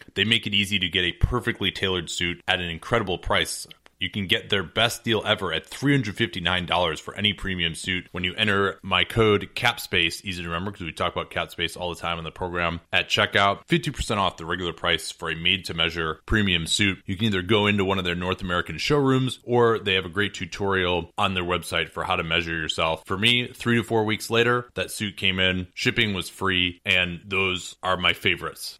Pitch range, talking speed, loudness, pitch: 85-105 Hz, 215 wpm, -23 LUFS, 95 Hz